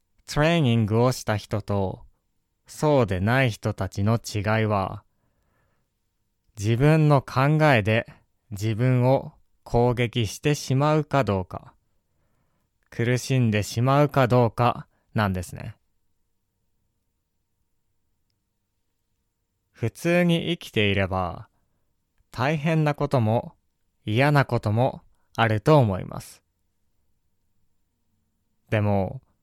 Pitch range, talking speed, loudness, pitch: 95-130 Hz, 180 characters per minute, -23 LUFS, 110 Hz